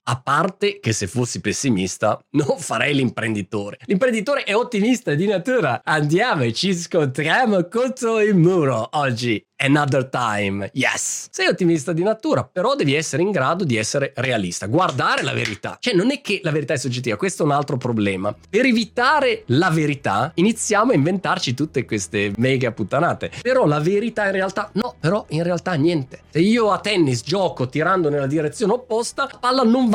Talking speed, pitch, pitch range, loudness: 175 wpm, 160 Hz, 130-205 Hz, -20 LUFS